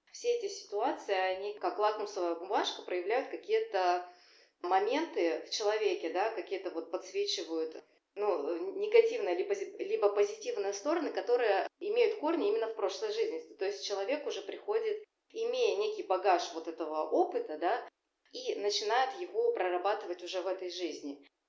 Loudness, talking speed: -33 LUFS, 135 wpm